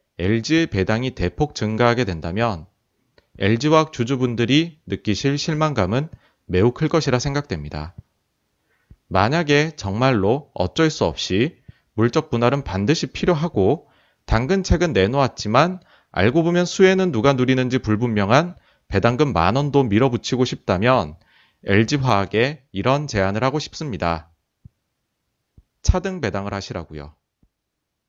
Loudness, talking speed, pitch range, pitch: -20 LUFS, 280 characters per minute, 100-150 Hz, 125 Hz